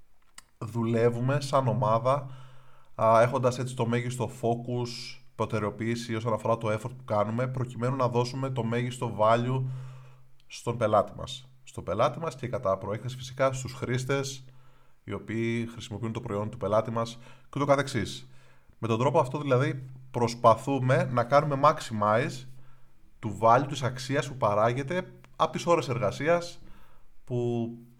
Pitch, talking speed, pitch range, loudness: 125 Hz, 140 wpm, 115-130 Hz, -28 LUFS